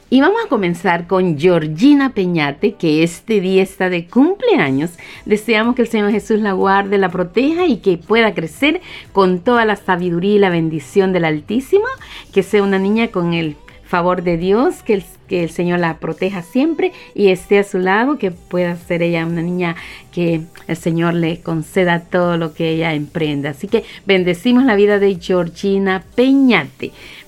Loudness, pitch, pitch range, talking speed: -16 LUFS, 190 Hz, 170-215 Hz, 180 wpm